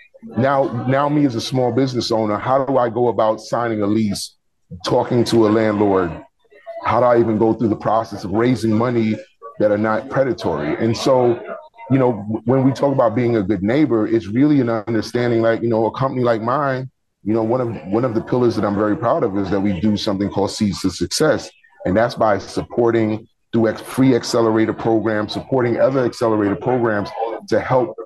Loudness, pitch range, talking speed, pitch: -18 LUFS, 110-125 Hz, 200 wpm, 115 Hz